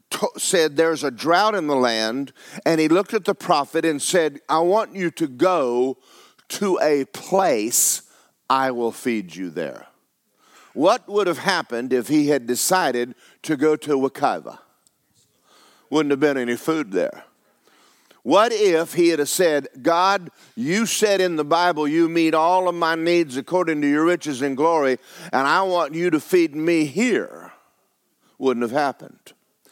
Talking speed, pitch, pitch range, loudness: 160 wpm, 160 Hz, 140-180 Hz, -20 LUFS